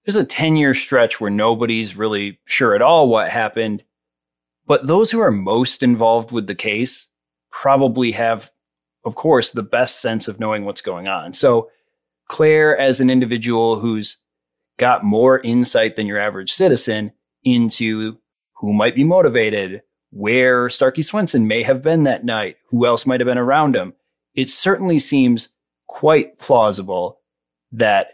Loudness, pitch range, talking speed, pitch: -16 LUFS, 110-135 Hz, 155 wpm, 115 Hz